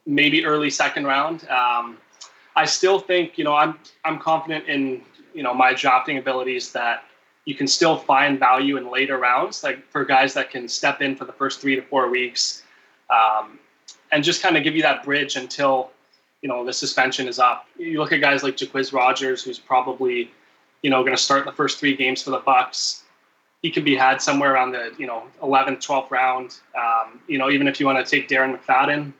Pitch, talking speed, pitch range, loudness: 135 Hz, 210 wpm, 130-145 Hz, -20 LUFS